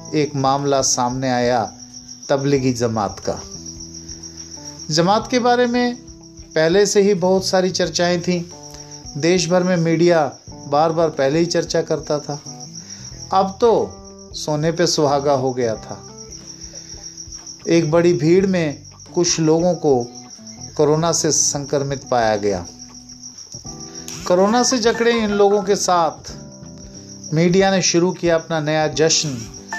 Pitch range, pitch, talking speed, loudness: 125-175 Hz, 150 Hz, 125 wpm, -18 LUFS